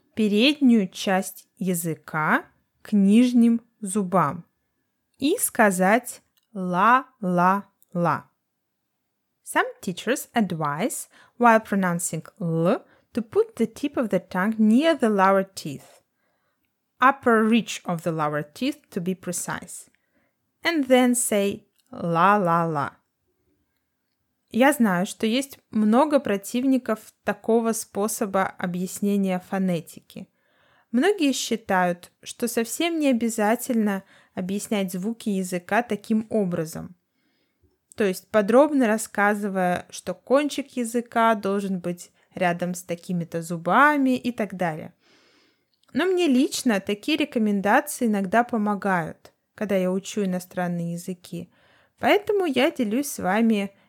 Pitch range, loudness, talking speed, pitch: 185-245 Hz, -23 LUFS, 105 wpm, 210 Hz